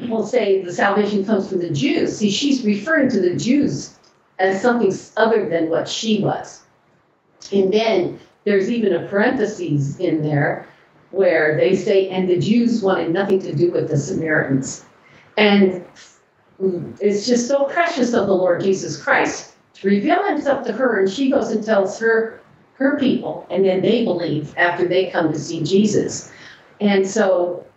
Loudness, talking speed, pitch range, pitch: -18 LUFS, 165 wpm, 175-225 Hz, 195 Hz